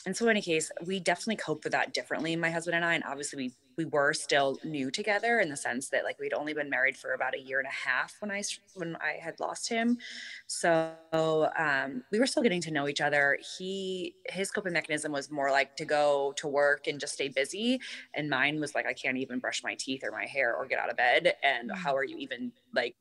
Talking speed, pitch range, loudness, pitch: 250 wpm, 145-200 Hz, -30 LUFS, 160 Hz